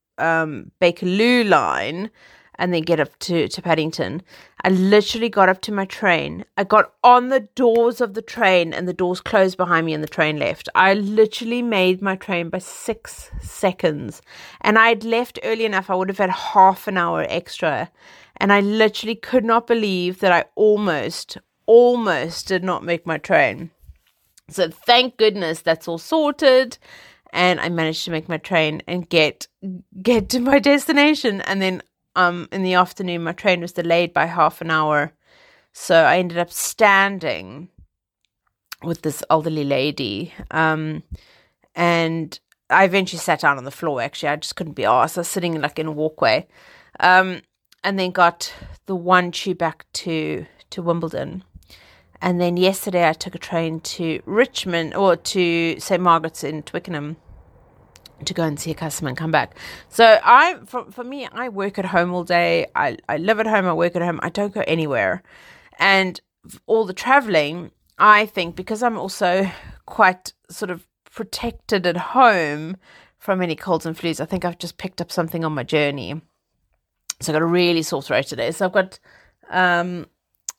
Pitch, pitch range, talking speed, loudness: 180 Hz, 165-205 Hz, 175 wpm, -19 LUFS